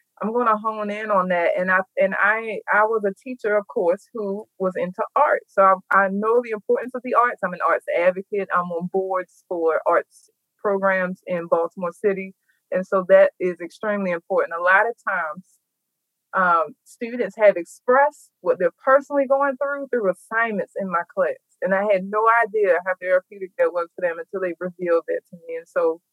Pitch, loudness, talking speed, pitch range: 205 Hz, -21 LUFS, 195 wpm, 185-245 Hz